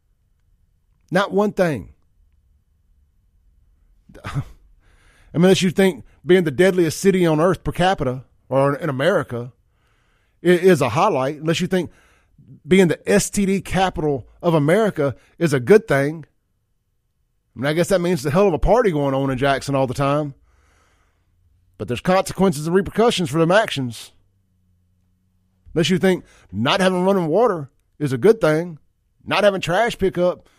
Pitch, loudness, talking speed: 140 Hz, -19 LUFS, 145 wpm